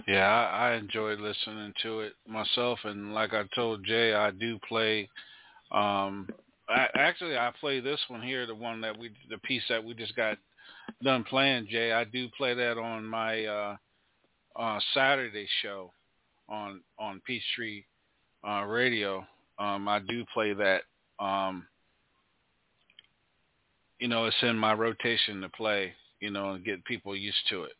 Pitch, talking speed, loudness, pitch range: 110 Hz, 160 wpm, -30 LUFS, 105-115 Hz